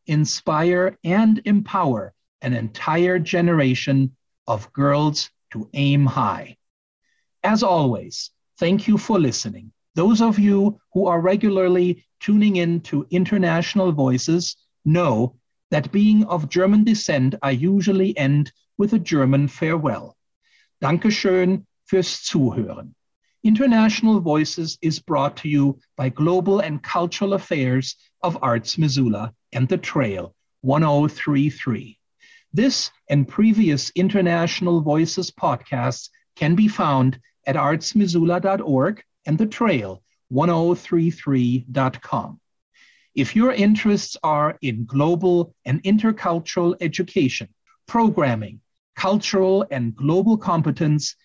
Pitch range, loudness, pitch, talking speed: 140-195 Hz, -20 LUFS, 170 Hz, 105 wpm